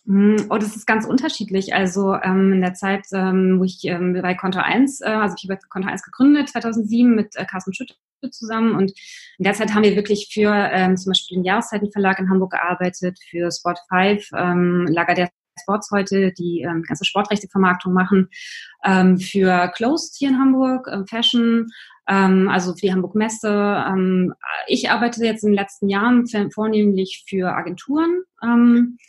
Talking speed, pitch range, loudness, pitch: 175 wpm, 185-225 Hz, -19 LUFS, 200 Hz